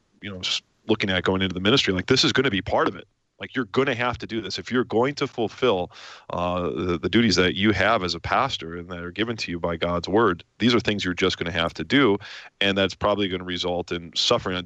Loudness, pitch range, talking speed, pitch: -23 LUFS, 90-115 Hz, 280 wpm, 95 Hz